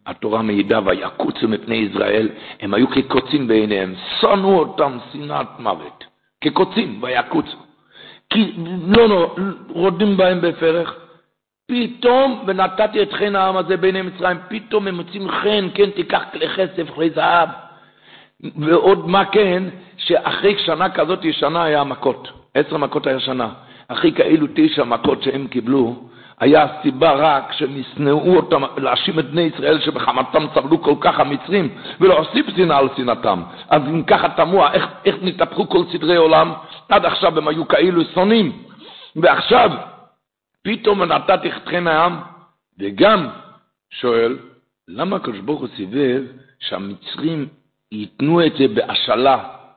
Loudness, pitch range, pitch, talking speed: -17 LUFS, 140-195 Hz, 170 Hz, 130 wpm